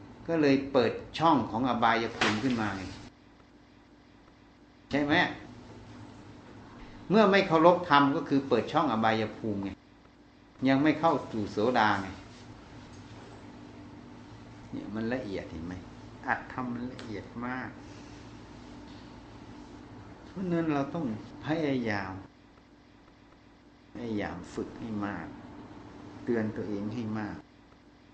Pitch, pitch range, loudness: 115 Hz, 100-140 Hz, -29 LUFS